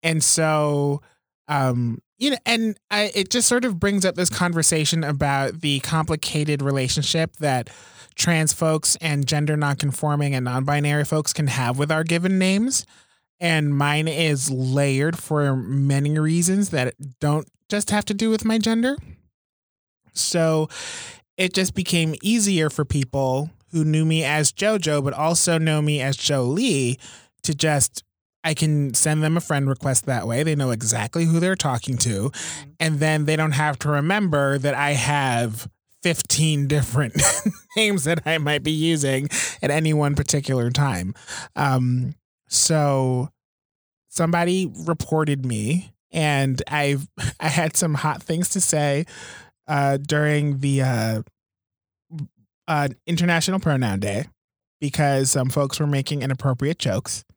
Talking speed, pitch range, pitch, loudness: 145 wpm, 135-165 Hz, 150 Hz, -21 LUFS